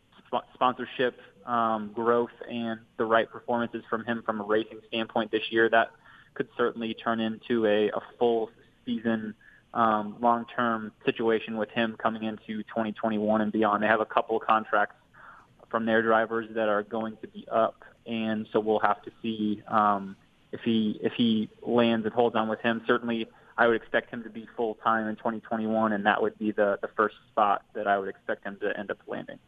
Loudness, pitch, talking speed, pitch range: -28 LUFS, 115 Hz, 195 wpm, 110-115 Hz